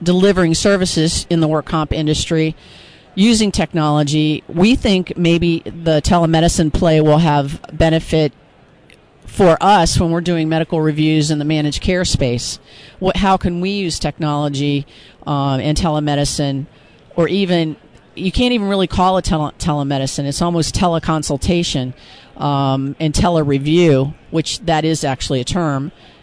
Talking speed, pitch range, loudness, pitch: 150 wpm, 145-175 Hz, -16 LUFS, 160 Hz